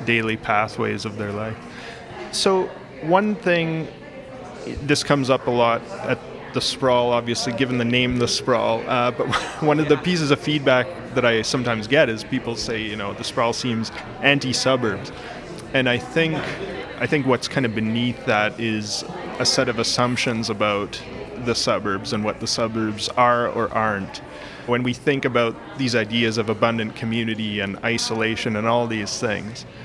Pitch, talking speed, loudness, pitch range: 120 Hz, 175 wpm, -21 LUFS, 110-130 Hz